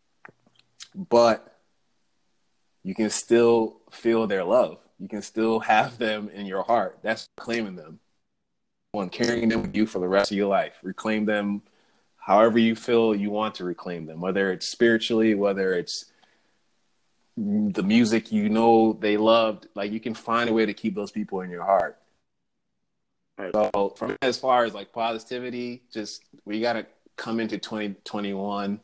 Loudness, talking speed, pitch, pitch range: -24 LUFS, 160 wpm, 110 Hz, 100-115 Hz